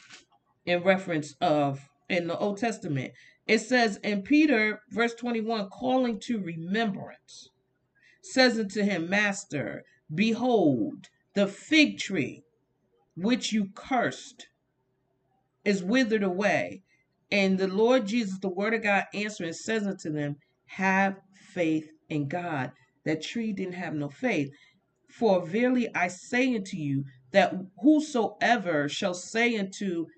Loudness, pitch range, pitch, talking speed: -27 LUFS, 155-225 Hz, 195 Hz, 125 wpm